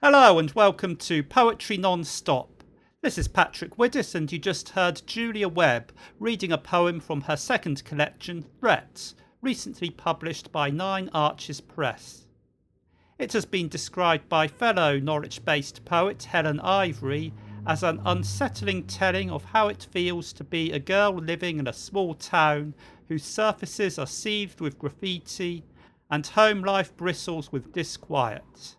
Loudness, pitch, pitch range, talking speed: -26 LUFS, 170 Hz, 150-195 Hz, 145 wpm